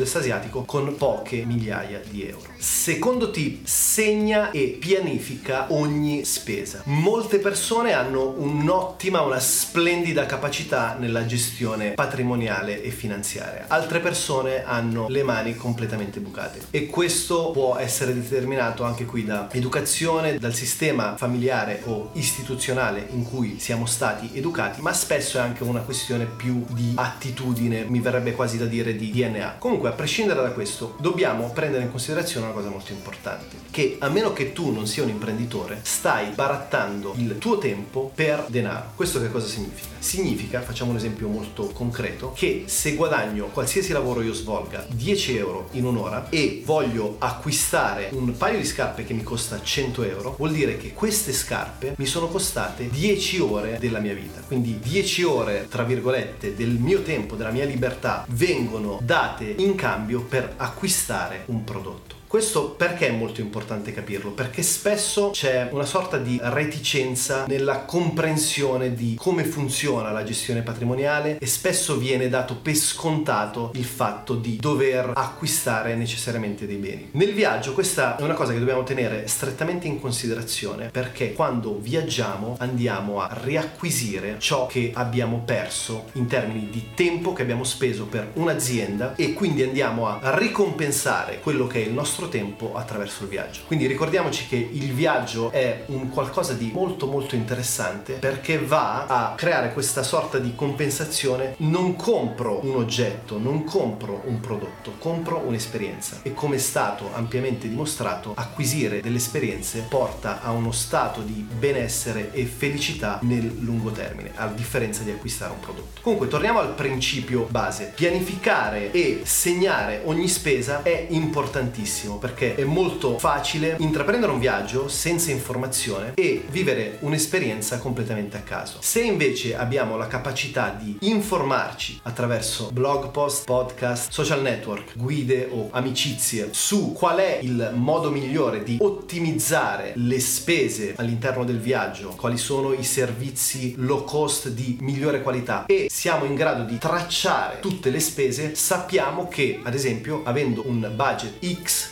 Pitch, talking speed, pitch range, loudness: 125 Hz, 150 wpm, 115-150 Hz, -24 LUFS